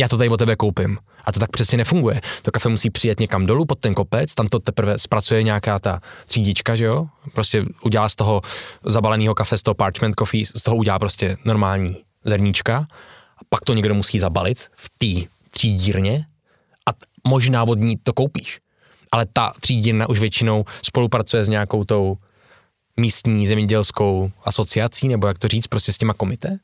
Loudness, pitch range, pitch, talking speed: -20 LUFS, 105-115 Hz, 110 Hz, 180 wpm